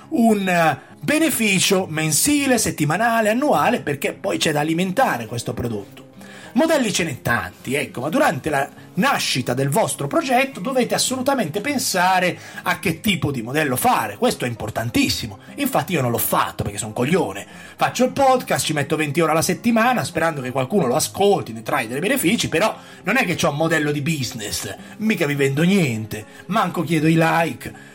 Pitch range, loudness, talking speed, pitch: 135-220 Hz, -20 LUFS, 175 wpm, 165 Hz